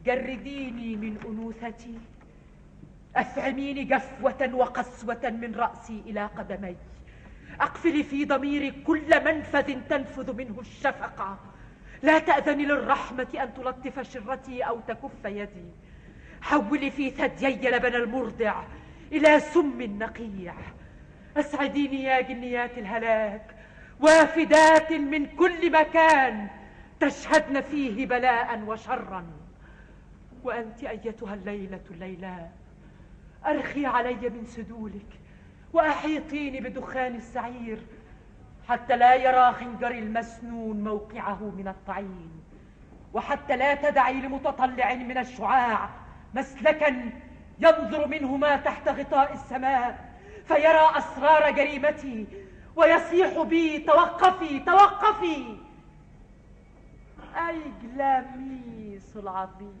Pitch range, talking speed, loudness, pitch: 230-290 Hz, 90 wpm, -25 LUFS, 260 Hz